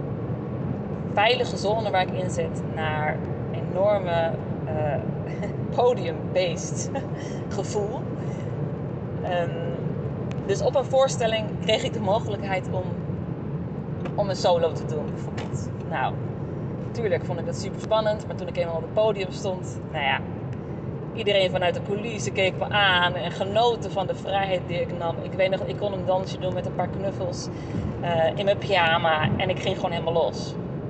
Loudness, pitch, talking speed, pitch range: -26 LUFS, 165 Hz, 160 wpm, 150-185 Hz